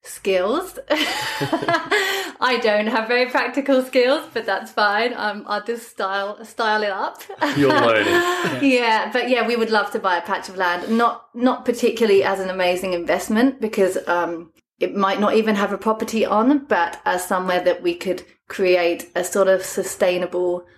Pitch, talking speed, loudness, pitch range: 215 Hz, 165 wpm, -20 LUFS, 185-245 Hz